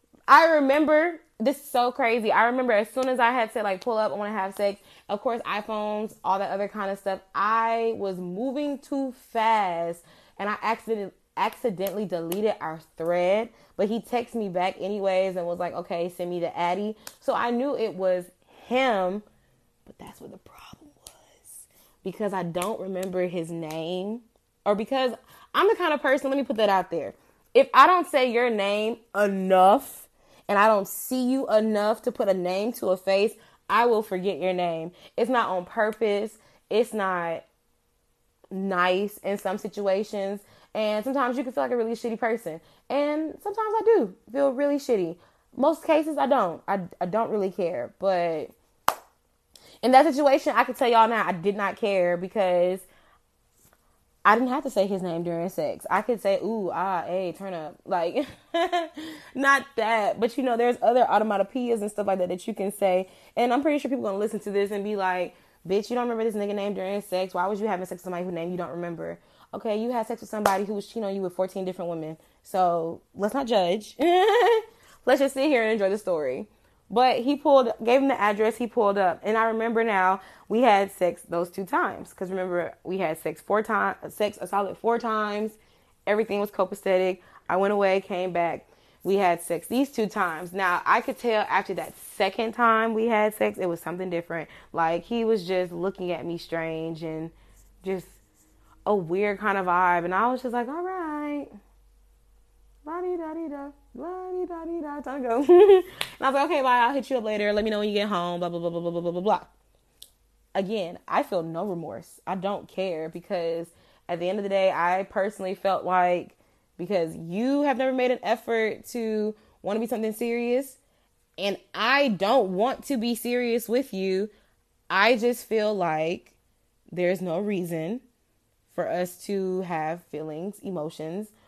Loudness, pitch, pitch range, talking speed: -25 LUFS, 205 Hz, 185-240 Hz, 195 wpm